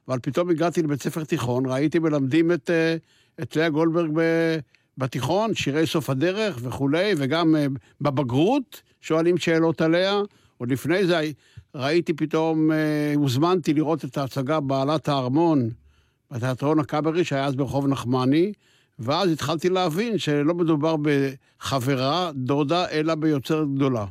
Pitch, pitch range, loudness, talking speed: 155 Hz, 135-165 Hz, -23 LUFS, 120 wpm